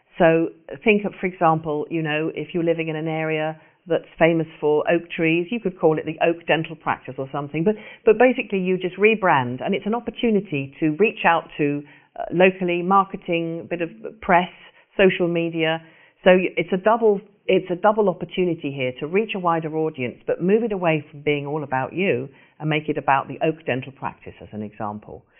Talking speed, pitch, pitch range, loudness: 200 wpm, 165 Hz, 150-185 Hz, -22 LUFS